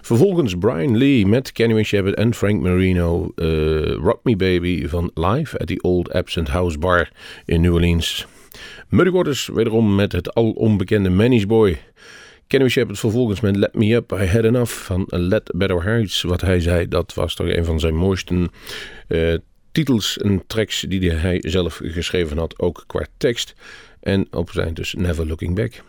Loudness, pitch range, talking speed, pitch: -19 LUFS, 85-110 Hz, 175 wpm, 95 Hz